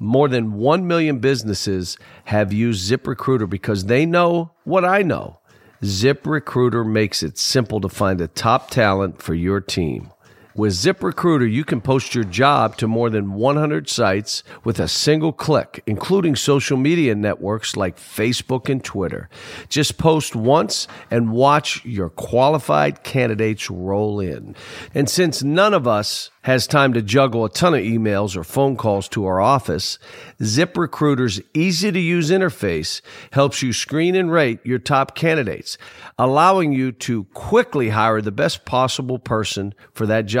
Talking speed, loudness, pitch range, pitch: 155 wpm, -19 LUFS, 105-145 Hz, 125 Hz